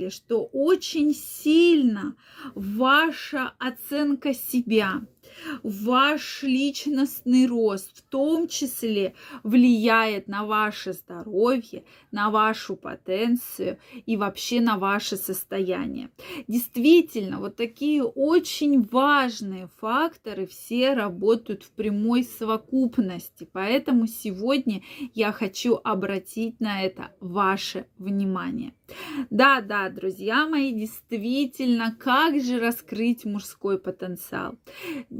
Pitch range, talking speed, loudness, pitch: 210-270 Hz, 90 wpm, -24 LUFS, 235 Hz